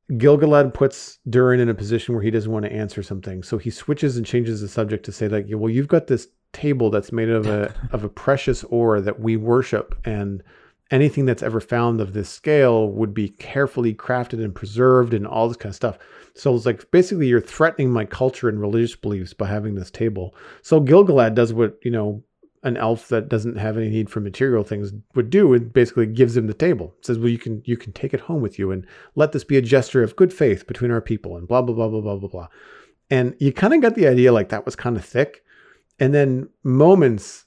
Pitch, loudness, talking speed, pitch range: 115 Hz, -20 LUFS, 235 wpm, 110-130 Hz